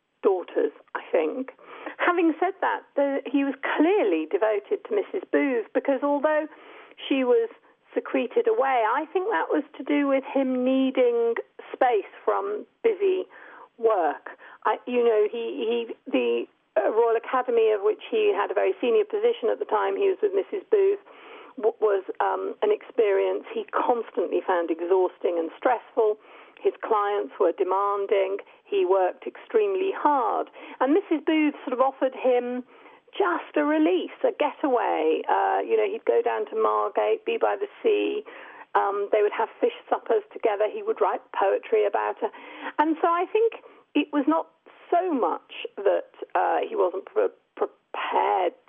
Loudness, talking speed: -25 LUFS, 160 wpm